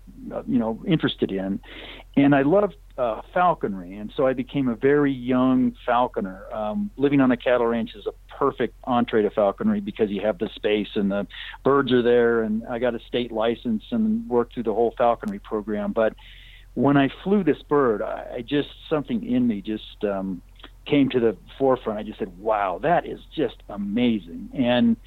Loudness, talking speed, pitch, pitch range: -23 LUFS, 190 wpm, 120 Hz, 110-140 Hz